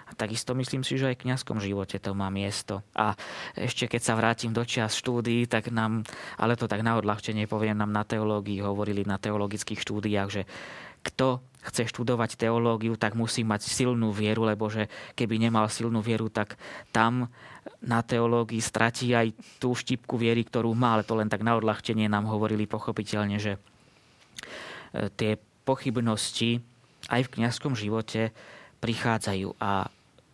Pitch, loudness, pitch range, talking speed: 115 Hz, -28 LUFS, 105-120 Hz, 155 wpm